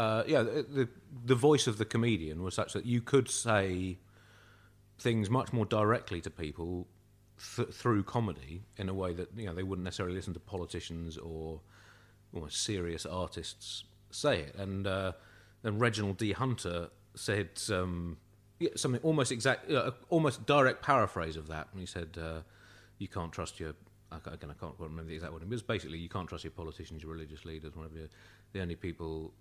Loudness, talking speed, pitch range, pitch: -34 LUFS, 195 wpm, 85-110 Hz, 100 Hz